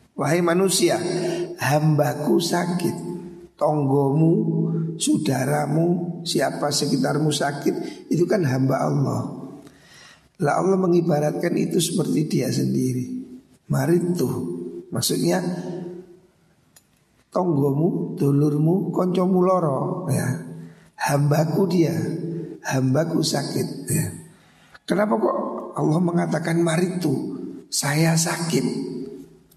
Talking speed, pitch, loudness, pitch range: 80 wpm, 165 Hz, -22 LUFS, 145-175 Hz